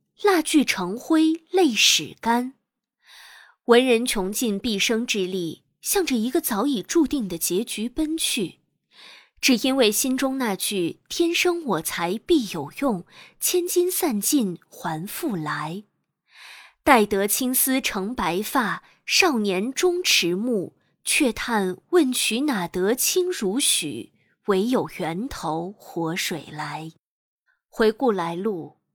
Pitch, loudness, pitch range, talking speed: 235 Hz, -22 LUFS, 190-285 Hz, 170 characters per minute